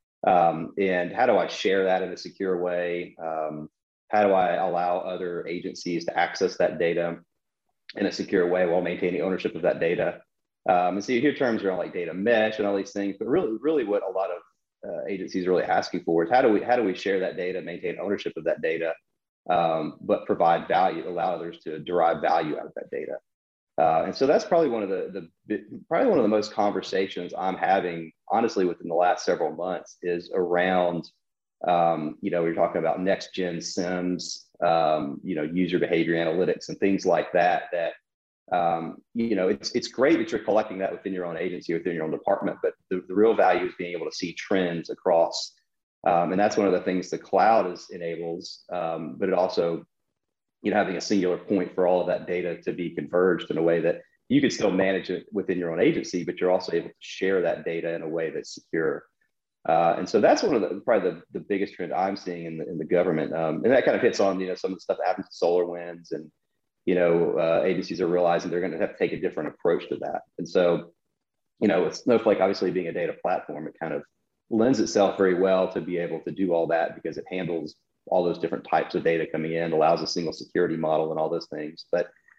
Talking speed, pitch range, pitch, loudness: 230 wpm, 85-95 Hz, 90 Hz, -25 LUFS